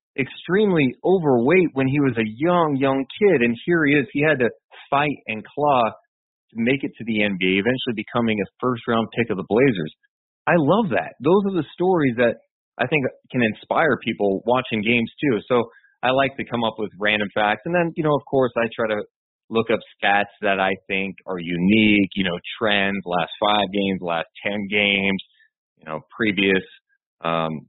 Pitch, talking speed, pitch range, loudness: 115 Hz, 195 wpm, 100-135 Hz, -21 LUFS